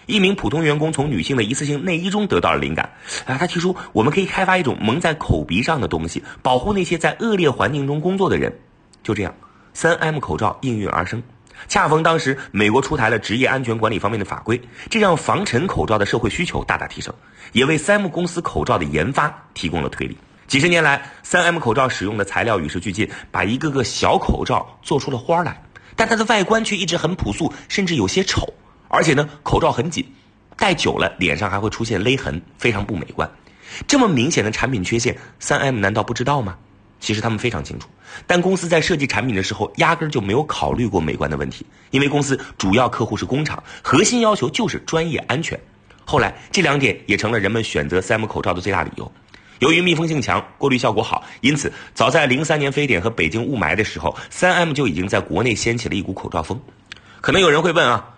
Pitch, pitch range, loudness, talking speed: 125 Hz, 105-165 Hz, -19 LUFS, 340 characters per minute